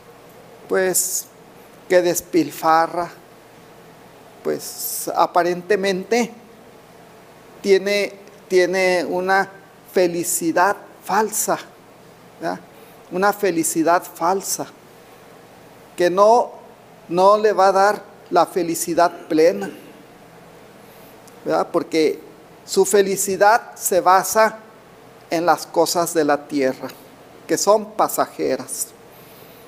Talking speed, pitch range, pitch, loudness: 80 wpm, 170-210 Hz, 190 Hz, -19 LUFS